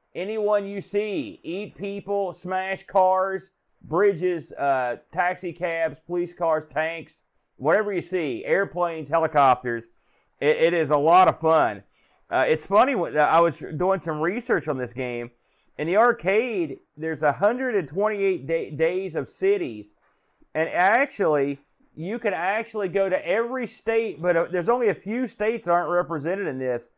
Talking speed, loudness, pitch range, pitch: 150 wpm, -24 LUFS, 160-205 Hz, 180 Hz